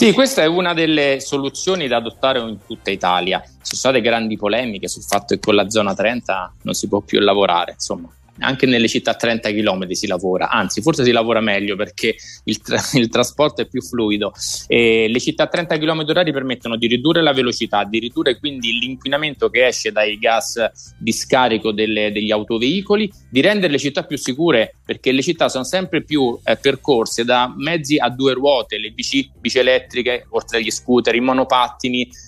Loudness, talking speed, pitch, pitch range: -17 LUFS, 190 wpm, 125 Hz, 115-145 Hz